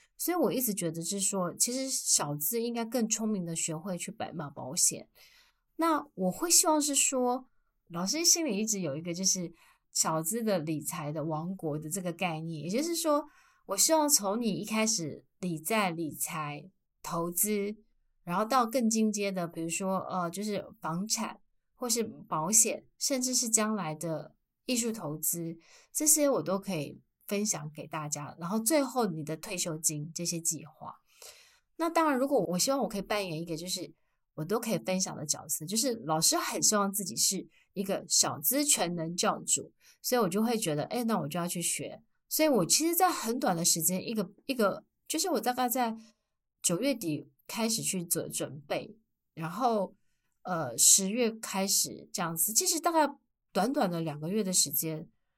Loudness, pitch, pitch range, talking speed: -29 LUFS, 195 Hz, 165-240 Hz, 260 characters per minute